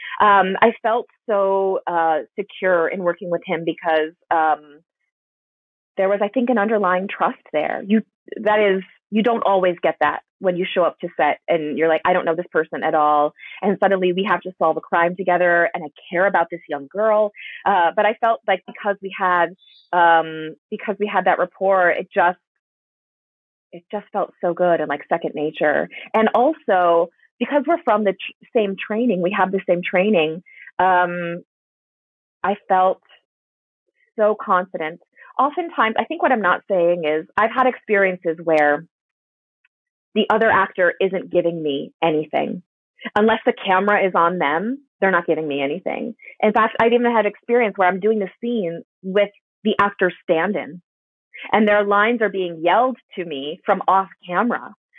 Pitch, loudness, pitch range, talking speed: 185 Hz, -19 LUFS, 170-210 Hz, 170 wpm